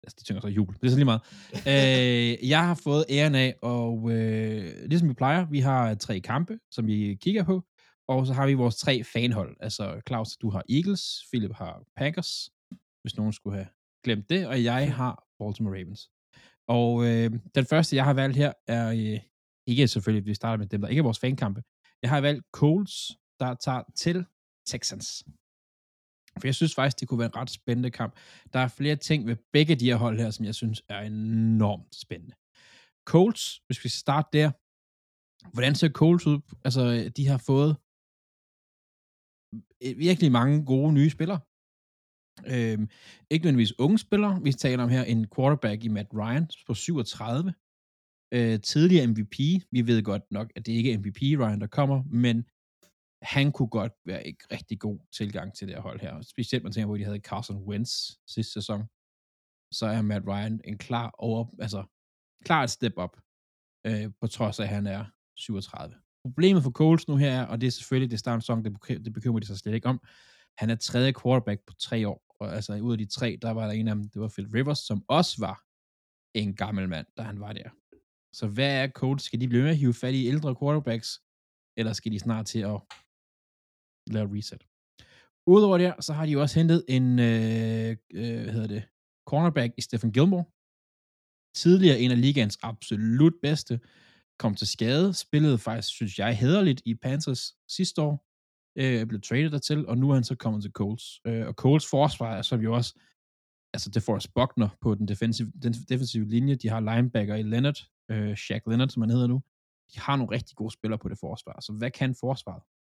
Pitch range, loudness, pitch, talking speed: 105-135 Hz, -27 LUFS, 115 Hz, 200 wpm